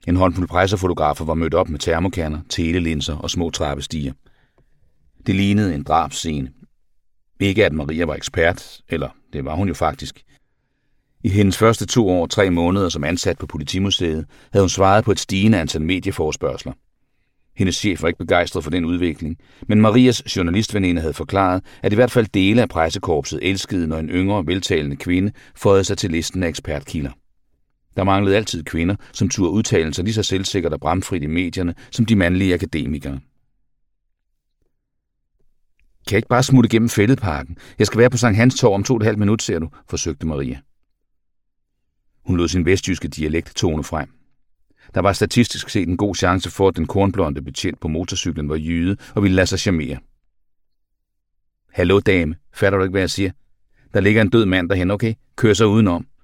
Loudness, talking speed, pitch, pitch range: -19 LUFS, 180 wpm, 95 Hz, 80-105 Hz